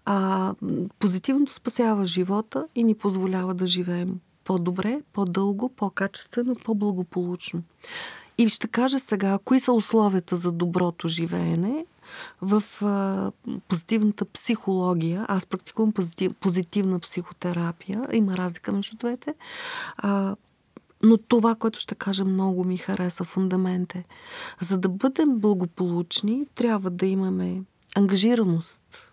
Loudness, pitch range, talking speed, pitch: -24 LUFS, 185-225 Hz, 115 wpm, 195 Hz